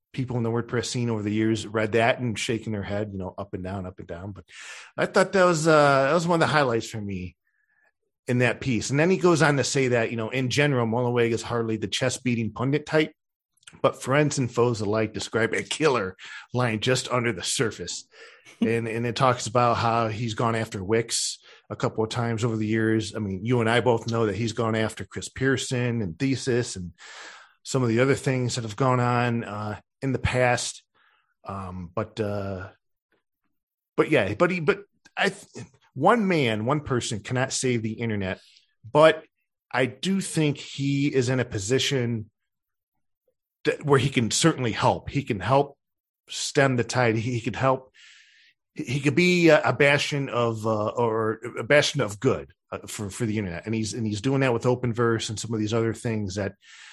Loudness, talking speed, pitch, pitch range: -24 LUFS, 205 wpm, 120 Hz, 110-135 Hz